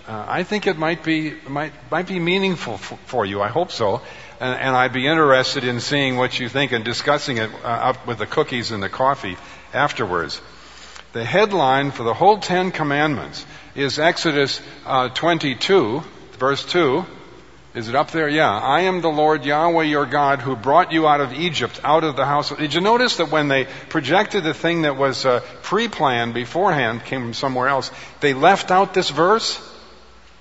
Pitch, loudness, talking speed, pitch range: 145 Hz, -19 LUFS, 195 wpm, 130-165 Hz